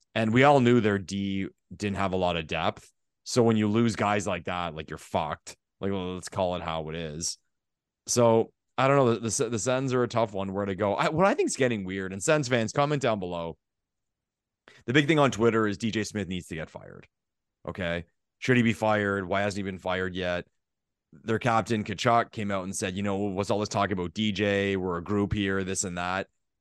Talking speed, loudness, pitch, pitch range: 230 wpm, -27 LUFS, 100 Hz, 95-115 Hz